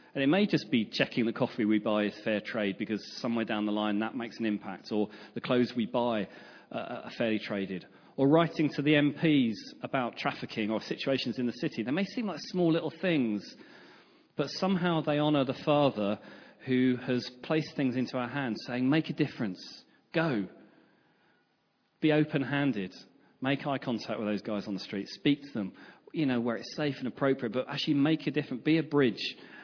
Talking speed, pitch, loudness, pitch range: 195 wpm, 125 Hz, -31 LUFS, 110-150 Hz